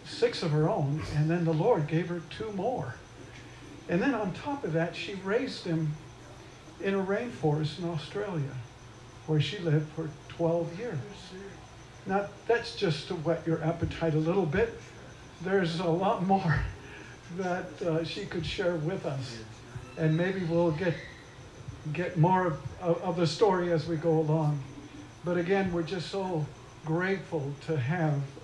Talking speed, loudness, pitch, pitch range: 160 wpm, -30 LUFS, 165 Hz, 145-180 Hz